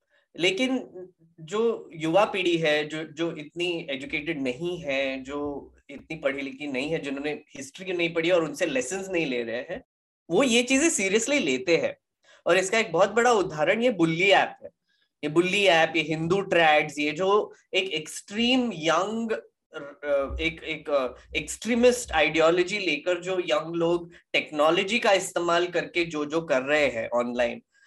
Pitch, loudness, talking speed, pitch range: 170 Hz, -25 LUFS, 155 wpm, 150-200 Hz